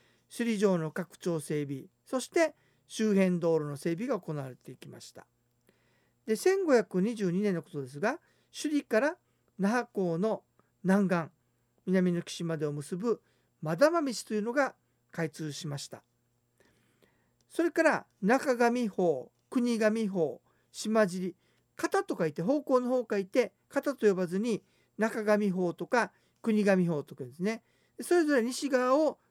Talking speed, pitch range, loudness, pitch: 215 characters per minute, 170-250 Hz, -30 LUFS, 210 Hz